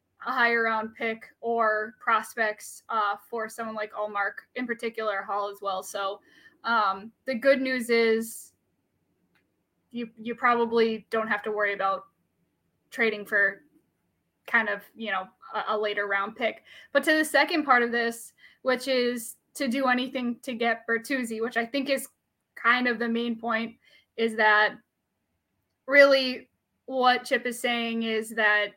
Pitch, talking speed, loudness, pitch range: 230 Hz, 155 wpm, -26 LUFS, 215-250 Hz